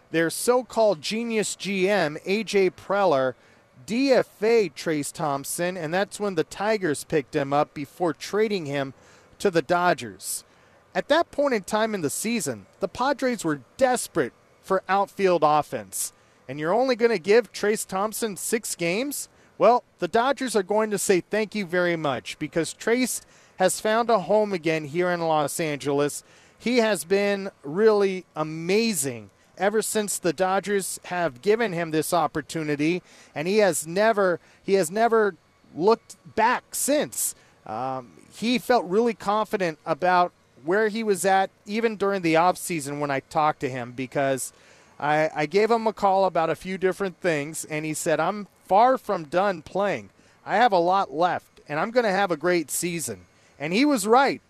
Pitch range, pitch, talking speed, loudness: 155-210 Hz, 185 Hz, 165 wpm, -24 LUFS